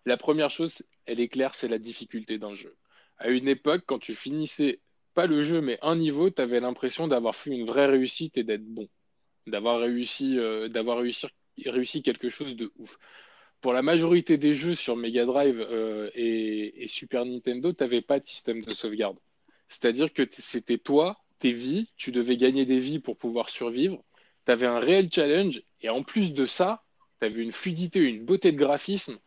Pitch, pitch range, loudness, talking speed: 130 Hz, 120-150 Hz, -27 LUFS, 195 wpm